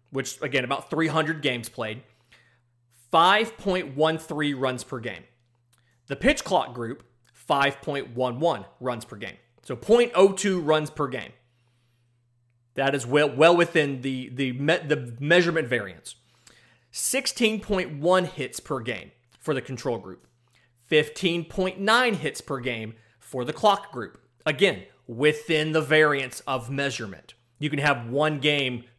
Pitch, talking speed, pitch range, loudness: 135 Hz, 125 wpm, 120-160 Hz, -24 LUFS